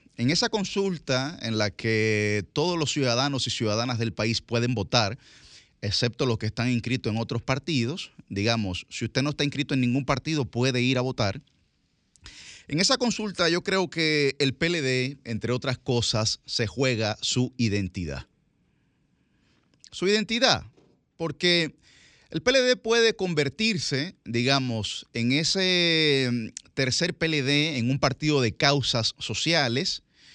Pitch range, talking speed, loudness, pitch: 115-155 Hz, 135 wpm, -25 LUFS, 130 Hz